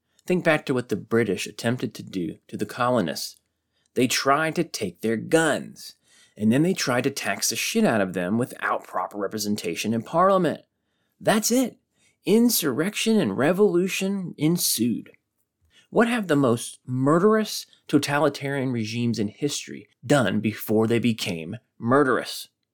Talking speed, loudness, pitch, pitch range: 145 wpm, -24 LUFS, 140 Hz, 115-180 Hz